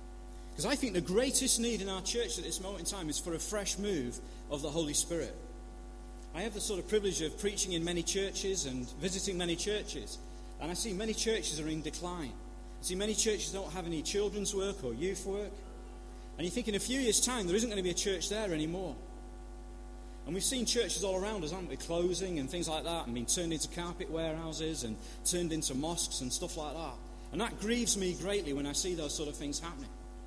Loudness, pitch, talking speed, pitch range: -34 LUFS, 175 Hz, 230 wpm, 145-200 Hz